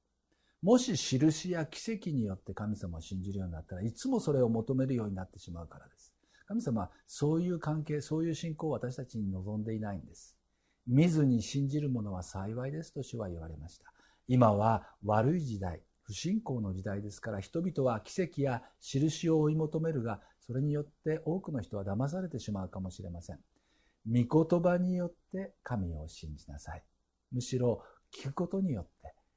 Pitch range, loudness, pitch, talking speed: 95-155 Hz, -34 LUFS, 125 Hz, 360 characters per minute